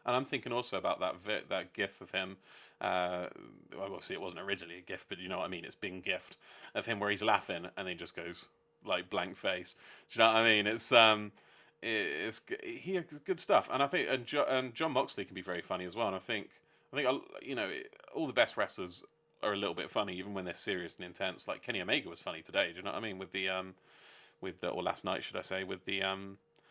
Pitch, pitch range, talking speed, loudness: 105 Hz, 95-130 Hz, 260 wpm, -35 LUFS